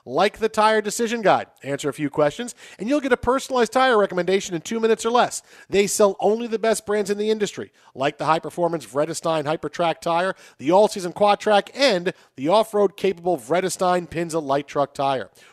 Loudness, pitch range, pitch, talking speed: -21 LUFS, 160-220 Hz, 190 Hz, 195 wpm